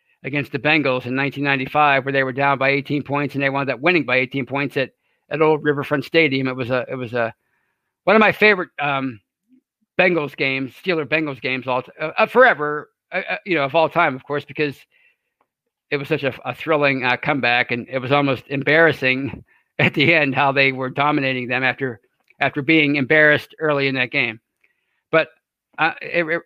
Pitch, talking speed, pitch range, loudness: 140 Hz, 195 wpm, 130-155 Hz, -19 LUFS